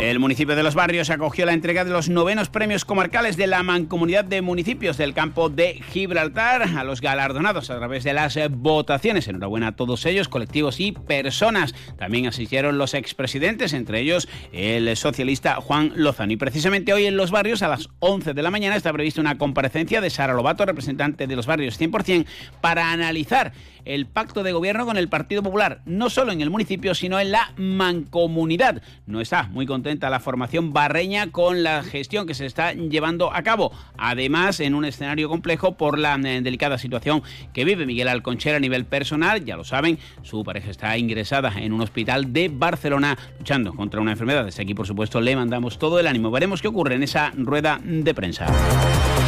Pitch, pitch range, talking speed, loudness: 150 Hz, 130-175 Hz, 190 wpm, -22 LUFS